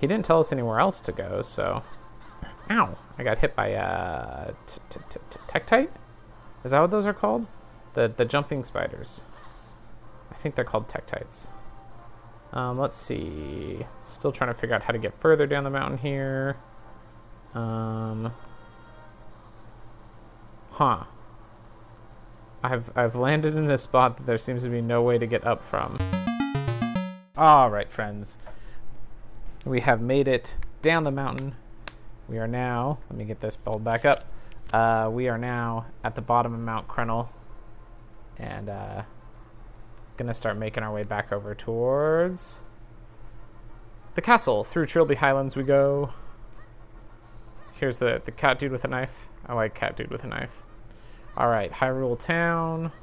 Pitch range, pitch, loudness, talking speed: 110-130 Hz, 115 Hz, -26 LUFS, 150 wpm